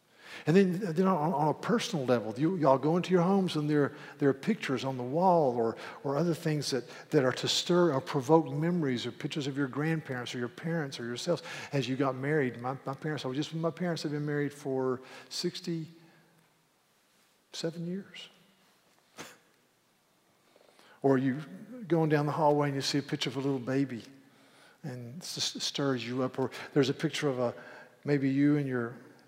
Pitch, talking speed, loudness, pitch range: 145 Hz, 185 wpm, -31 LUFS, 135-165 Hz